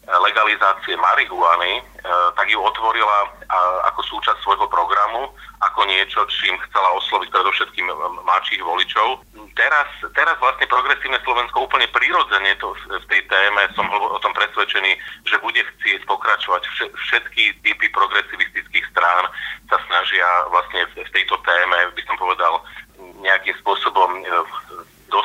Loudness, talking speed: -17 LUFS, 120 wpm